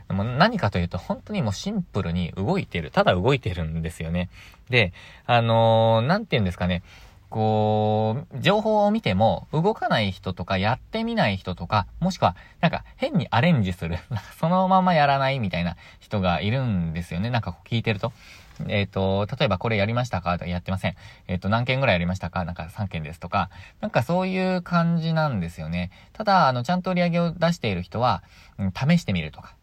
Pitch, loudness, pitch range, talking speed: 105 Hz, -24 LUFS, 90-150 Hz, 415 characters per minute